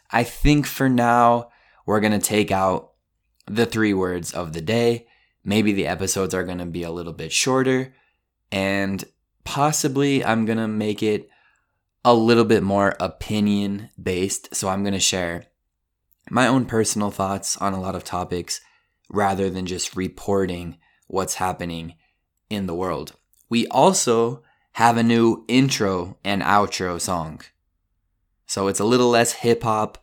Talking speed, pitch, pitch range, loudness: 150 wpm, 100 Hz, 95-115 Hz, -21 LUFS